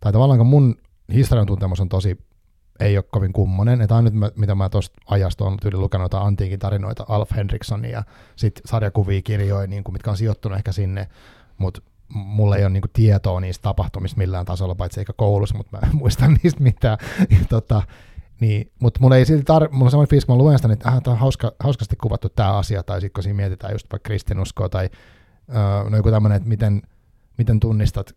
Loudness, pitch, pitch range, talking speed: -19 LUFS, 105 Hz, 100-115 Hz, 190 wpm